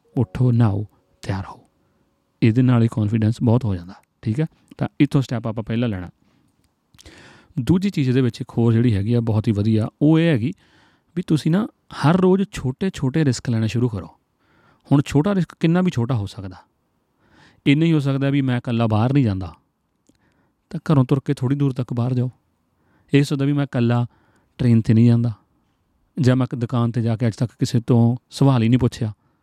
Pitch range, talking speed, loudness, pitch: 115-140 Hz, 195 wpm, -20 LUFS, 125 Hz